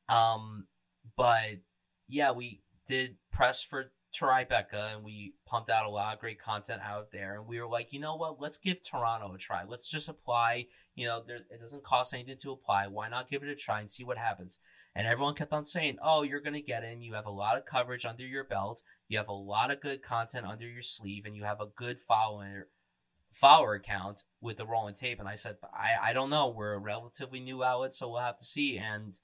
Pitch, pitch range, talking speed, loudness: 115 Hz, 100-130 Hz, 230 wpm, -33 LUFS